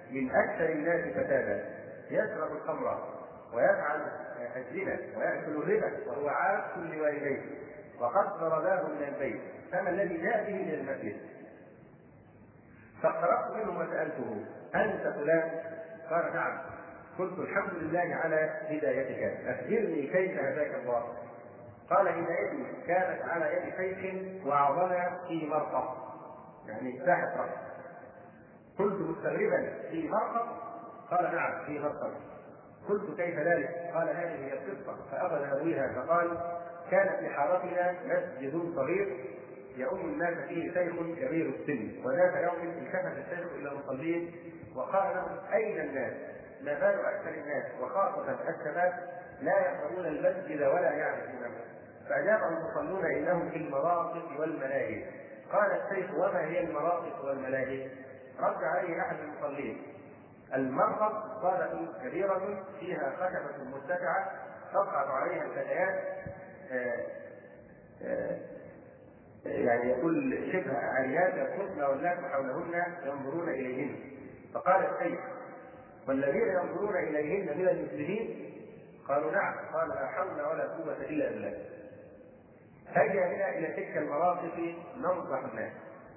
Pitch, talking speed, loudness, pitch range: 170 Hz, 110 wpm, -33 LUFS, 145-185 Hz